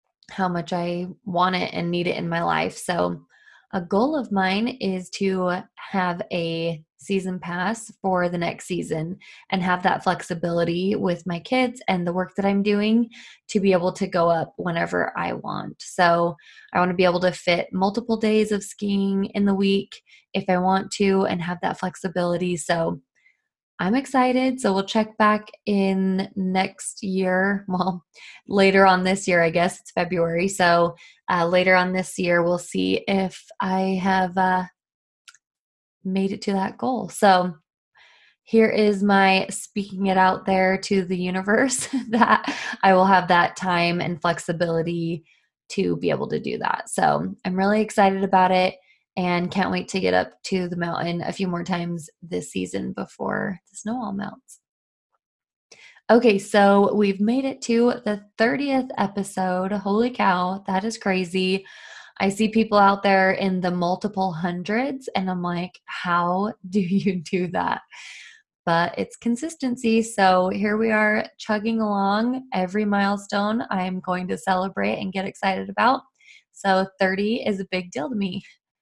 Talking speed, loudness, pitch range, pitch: 165 wpm, -22 LUFS, 180-210 Hz, 190 Hz